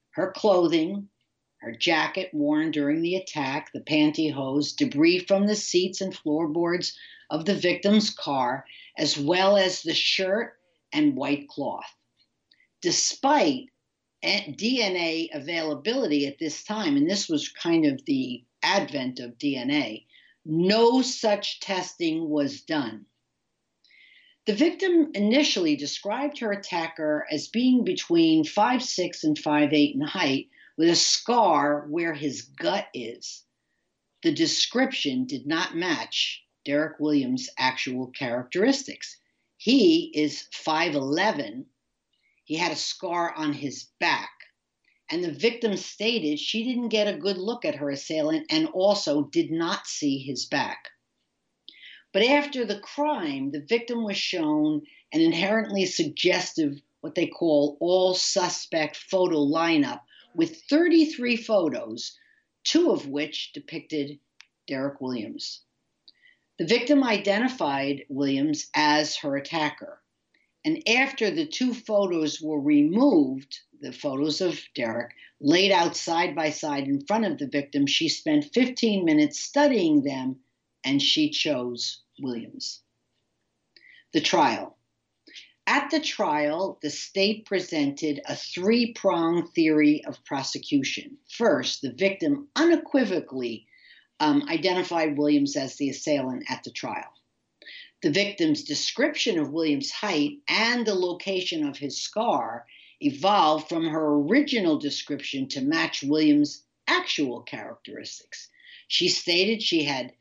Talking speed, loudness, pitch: 125 wpm, -25 LUFS, 200 Hz